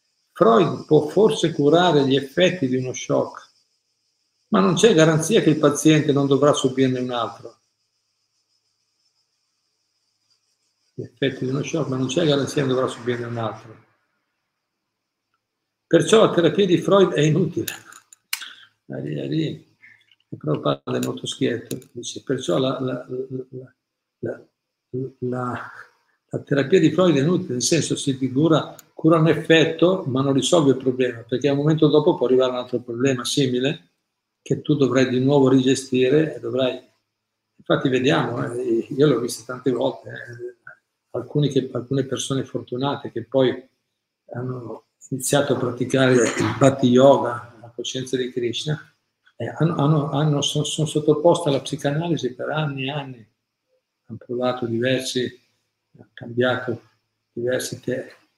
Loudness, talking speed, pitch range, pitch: -20 LUFS, 140 wpm, 120-150 Hz, 130 Hz